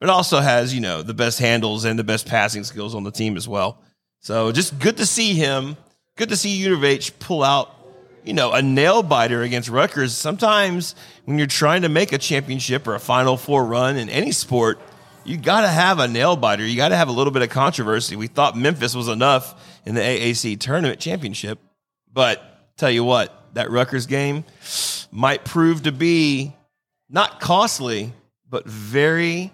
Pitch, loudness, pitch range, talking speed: 135 Hz, -19 LUFS, 115-155 Hz, 190 wpm